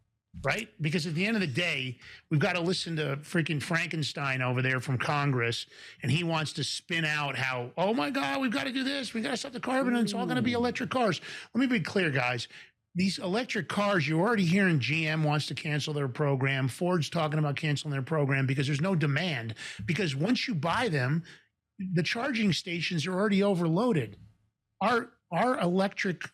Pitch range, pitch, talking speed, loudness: 145-200 Hz, 165 Hz, 205 wpm, -29 LUFS